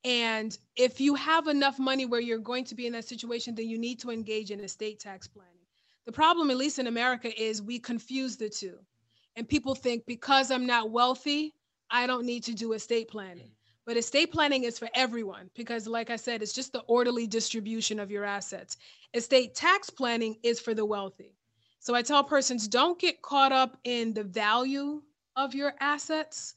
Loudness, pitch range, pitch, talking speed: -29 LUFS, 220-265 Hz, 235 Hz, 195 wpm